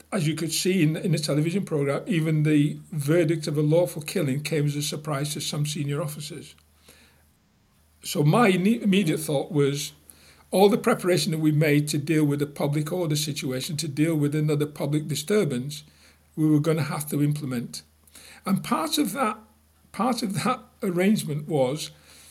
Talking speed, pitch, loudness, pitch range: 170 wpm, 155 Hz, -24 LUFS, 145-175 Hz